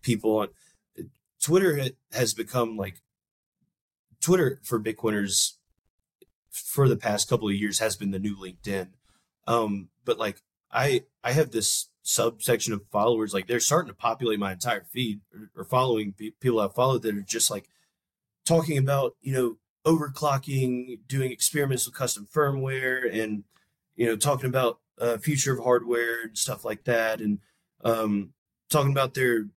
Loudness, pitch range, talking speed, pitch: -26 LUFS, 105-135 Hz, 155 wpm, 120 Hz